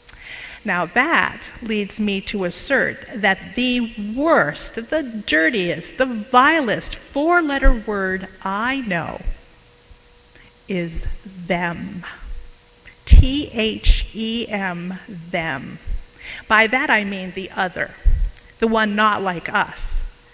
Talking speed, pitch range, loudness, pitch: 105 wpm, 185-245 Hz, -20 LUFS, 210 Hz